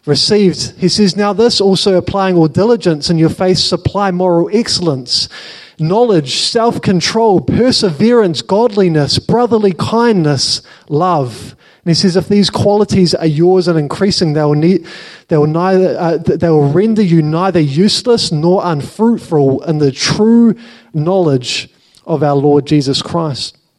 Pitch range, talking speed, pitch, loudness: 155-200 Hz, 140 wpm, 175 Hz, -12 LUFS